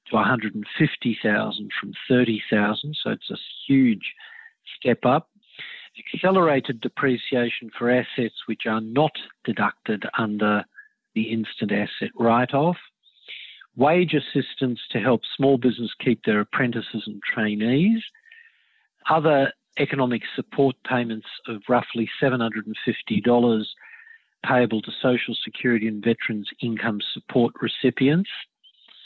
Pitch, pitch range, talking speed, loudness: 125 Hz, 115-155 Hz, 105 wpm, -23 LUFS